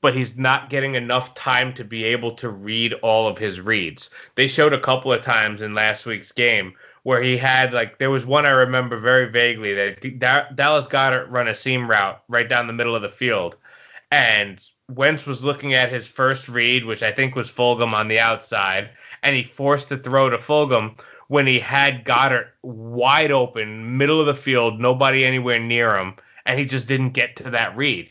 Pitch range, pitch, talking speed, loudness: 115-135 Hz, 125 Hz, 205 wpm, -19 LUFS